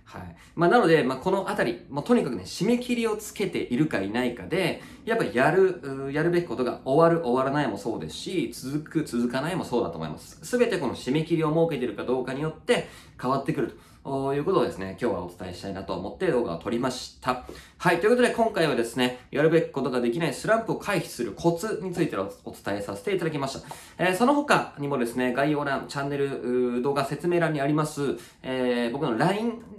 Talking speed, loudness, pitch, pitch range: 460 characters per minute, -26 LUFS, 145 Hz, 125-175 Hz